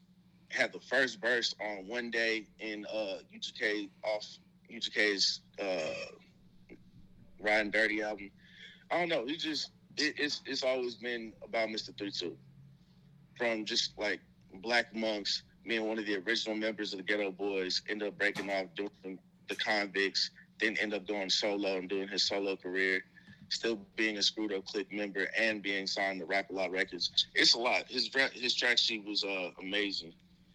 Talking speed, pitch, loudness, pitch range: 170 wpm, 105 Hz, -33 LUFS, 100-115 Hz